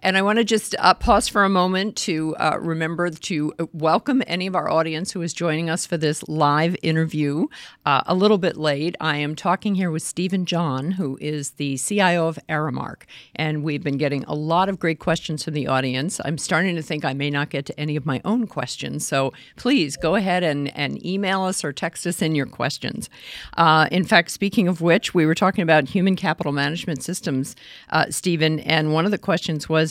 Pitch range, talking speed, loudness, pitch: 150-180 Hz, 215 wpm, -21 LUFS, 160 Hz